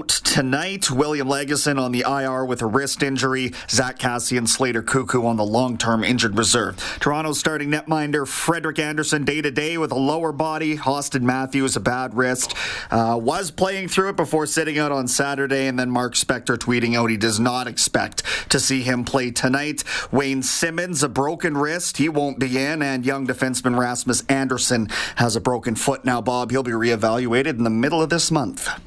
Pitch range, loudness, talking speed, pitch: 125-150 Hz, -20 LUFS, 190 wpm, 135 Hz